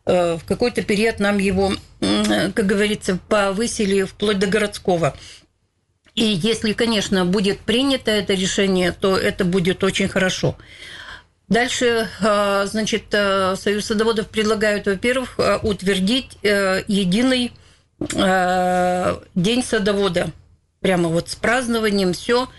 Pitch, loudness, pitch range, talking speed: 205 Hz, -19 LUFS, 190-220 Hz, 100 wpm